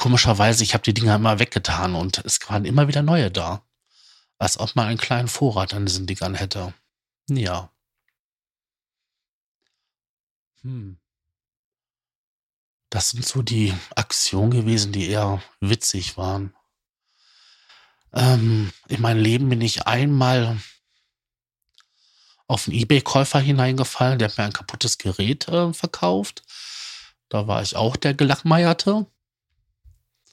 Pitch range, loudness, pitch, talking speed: 100-125 Hz, -21 LUFS, 115 Hz, 120 wpm